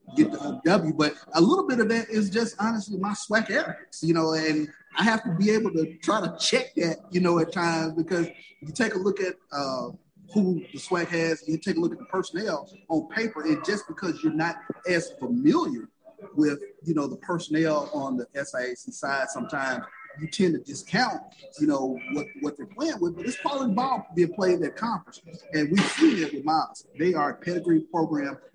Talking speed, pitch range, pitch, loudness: 210 wpm, 160-220 Hz, 175 Hz, -26 LUFS